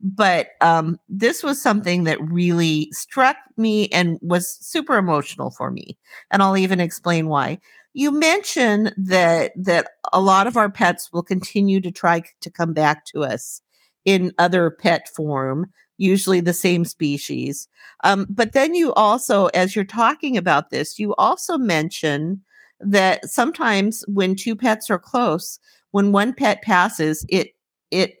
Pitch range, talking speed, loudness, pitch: 170-220 Hz, 155 wpm, -19 LUFS, 190 Hz